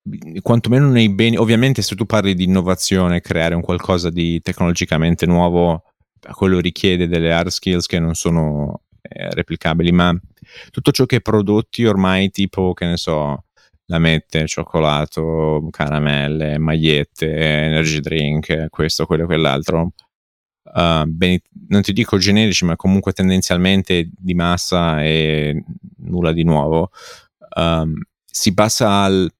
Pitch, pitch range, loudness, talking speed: 85 Hz, 80-95 Hz, -16 LUFS, 135 wpm